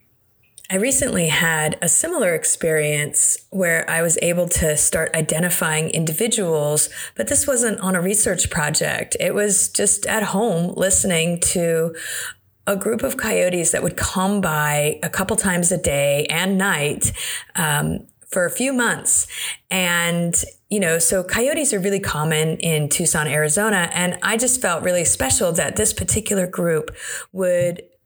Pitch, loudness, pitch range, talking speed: 175 Hz, -18 LUFS, 160-200 Hz, 150 wpm